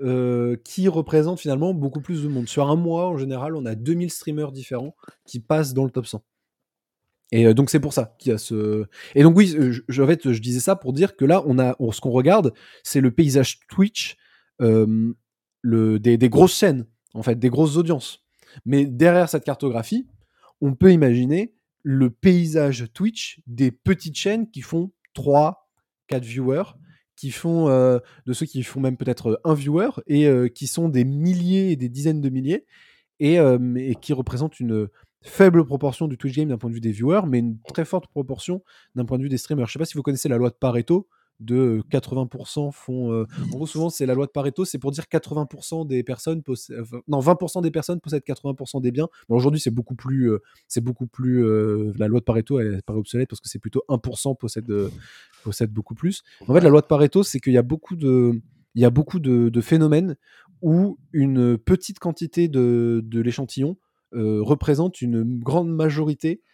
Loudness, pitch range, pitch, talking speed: -21 LUFS, 125-160 Hz, 135 Hz, 205 wpm